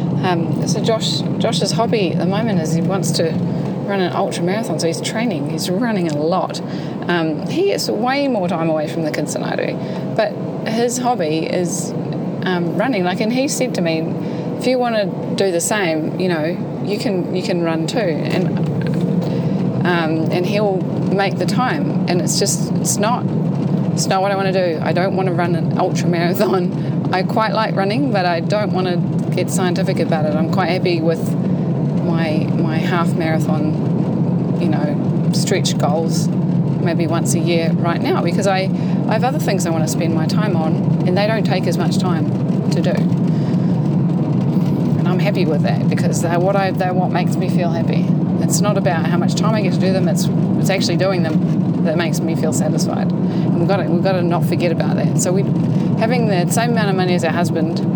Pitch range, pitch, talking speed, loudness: 165-180 Hz, 170 Hz, 205 wpm, -17 LUFS